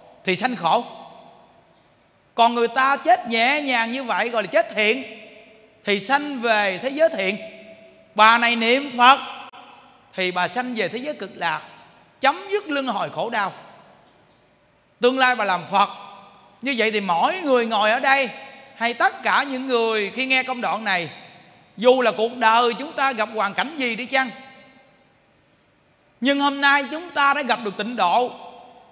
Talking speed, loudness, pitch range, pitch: 175 wpm, -20 LUFS, 215-265 Hz, 240 Hz